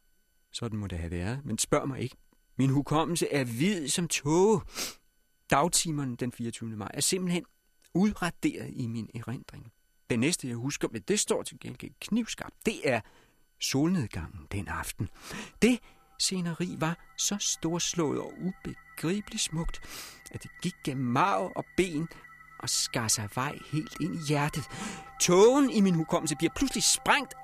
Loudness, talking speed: -29 LUFS, 155 wpm